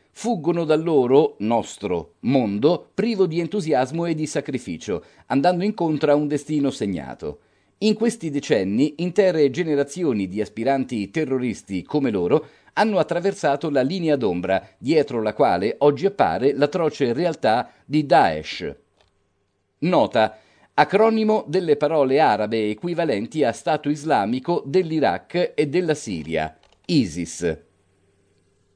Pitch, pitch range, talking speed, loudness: 145 Hz, 105-170 Hz, 115 wpm, -21 LUFS